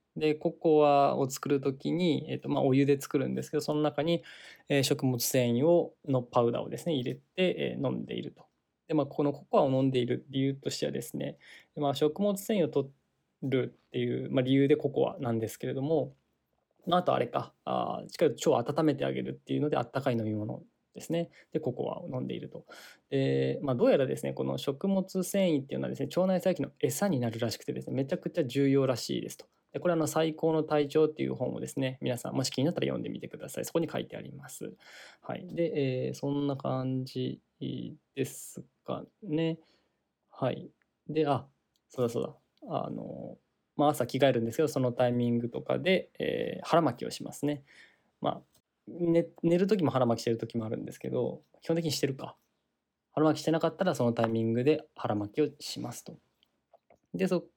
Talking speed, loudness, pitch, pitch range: 395 characters per minute, -31 LUFS, 140 Hz, 125-160 Hz